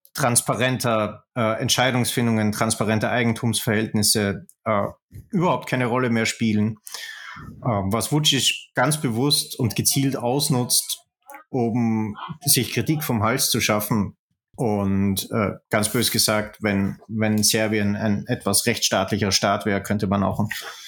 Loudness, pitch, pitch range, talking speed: -21 LUFS, 115 Hz, 105-125 Hz, 120 wpm